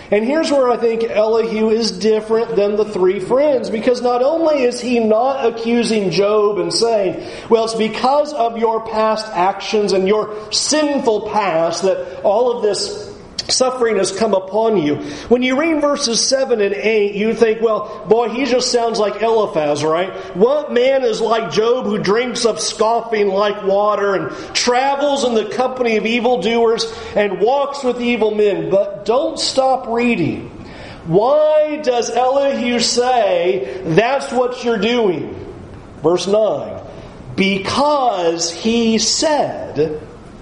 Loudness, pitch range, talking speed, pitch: -16 LUFS, 205-245 Hz, 145 wpm, 225 Hz